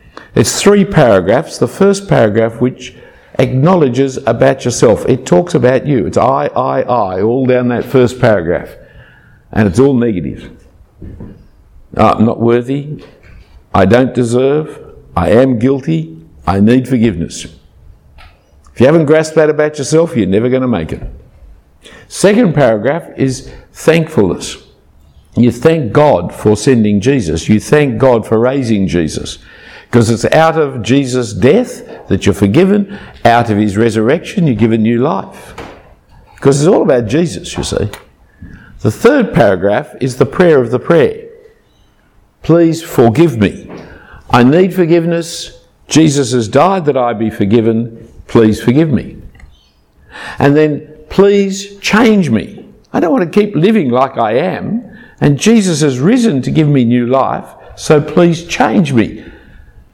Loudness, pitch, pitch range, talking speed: -11 LUFS, 130 Hz, 110-160 Hz, 145 wpm